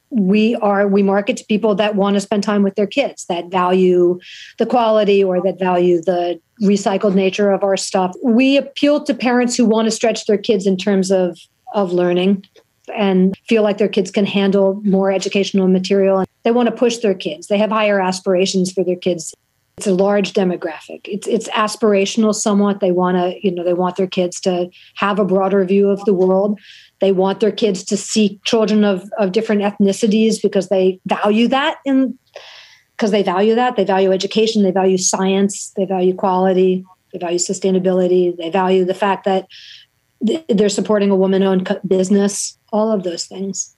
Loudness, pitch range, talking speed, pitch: -16 LUFS, 185-215 Hz, 185 wpm, 200 Hz